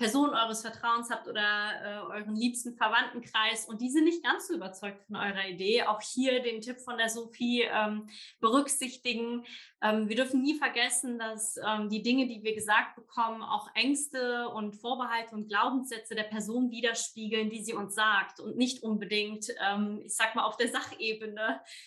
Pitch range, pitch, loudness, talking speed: 215-245 Hz, 230 Hz, -31 LUFS, 175 wpm